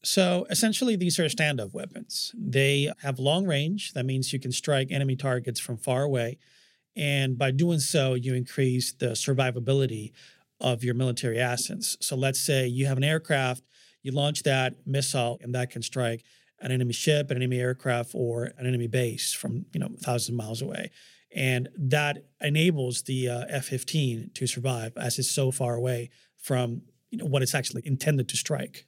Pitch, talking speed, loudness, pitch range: 130 Hz, 180 wpm, -27 LUFS, 125-145 Hz